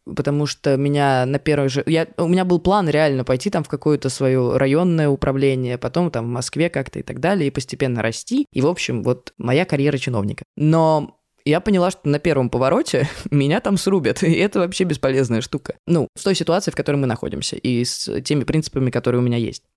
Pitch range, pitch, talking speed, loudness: 130-165 Hz, 145 Hz, 205 wpm, -19 LUFS